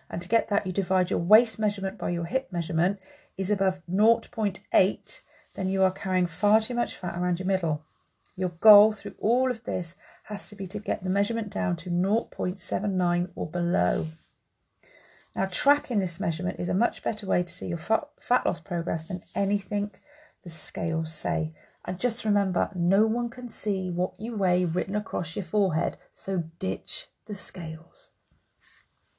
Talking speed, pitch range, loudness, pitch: 175 wpm, 175-210 Hz, -27 LUFS, 190 Hz